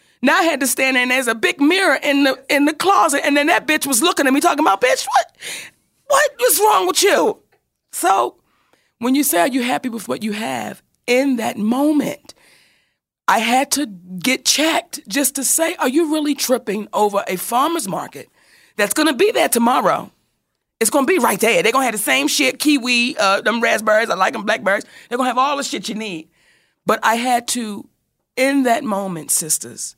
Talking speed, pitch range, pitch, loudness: 215 wpm, 220-300 Hz, 260 Hz, -17 LUFS